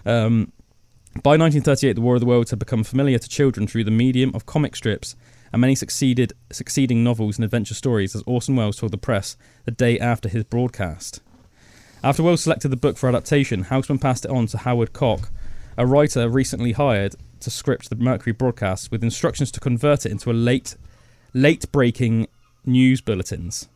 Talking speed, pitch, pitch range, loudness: 180 wpm, 120 Hz, 110-130 Hz, -20 LUFS